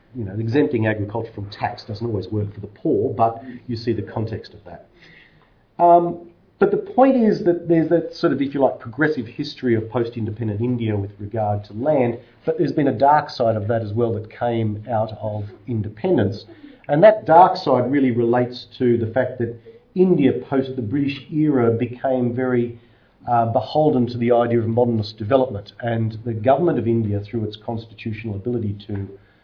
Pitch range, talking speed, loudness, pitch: 110-140 Hz, 185 wpm, -20 LUFS, 120 Hz